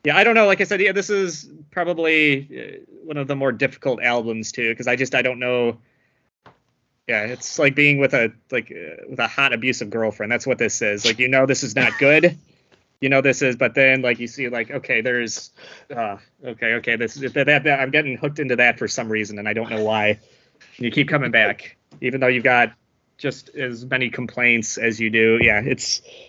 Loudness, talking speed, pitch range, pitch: -19 LUFS, 225 wpm, 115-145 Hz, 130 Hz